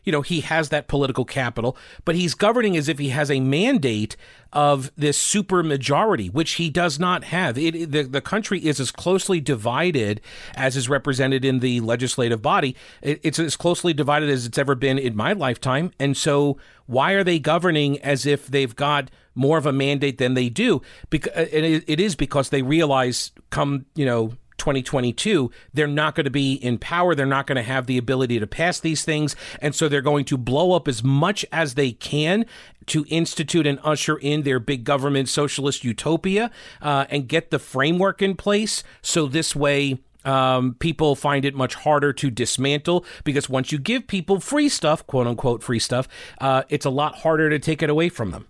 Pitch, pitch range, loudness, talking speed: 145 Hz, 135-160 Hz, -21 LUFS, 200 wpm